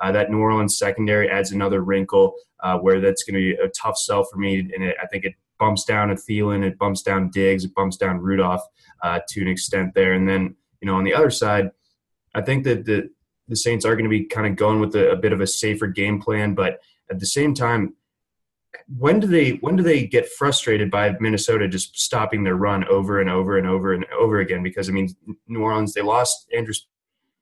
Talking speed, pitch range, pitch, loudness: 235 wpm, 95-110 Hz, 100 Hz, -20 LUFS